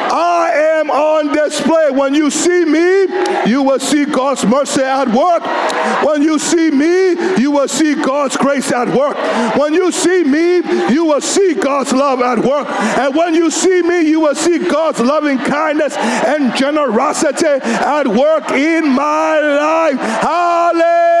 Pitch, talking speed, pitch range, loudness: 300 Hz, 160 wpm, 280-335 Hz, -13 LUFS